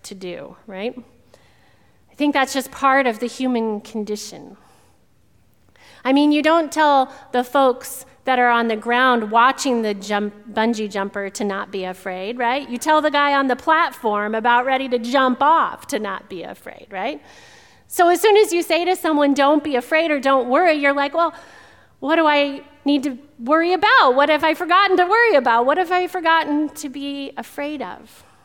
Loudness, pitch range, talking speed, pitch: -18 LUFS, 235-305 Hz, 190 wpm, 270 Hz